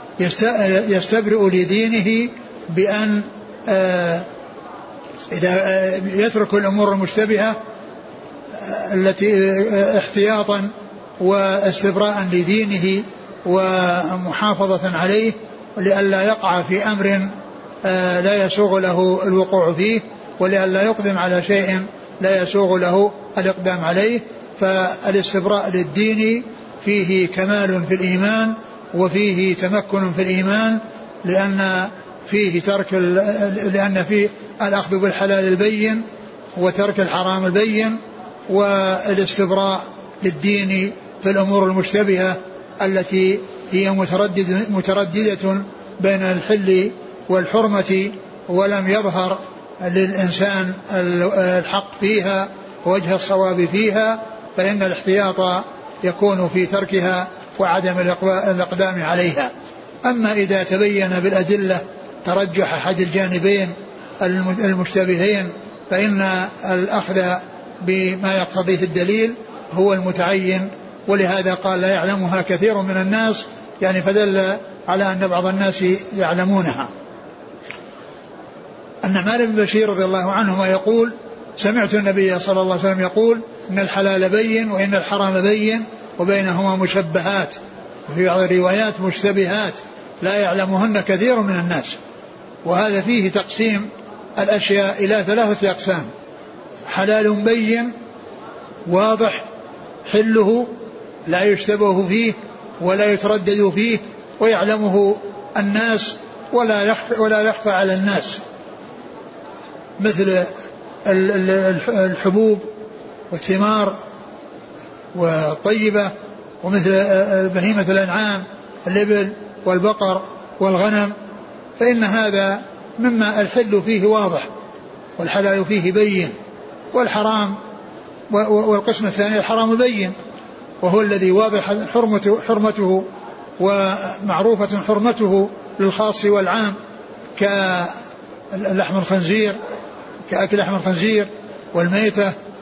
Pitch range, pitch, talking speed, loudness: 190-210 Hz, 195 Hz, 85 wpm, -18 LUFS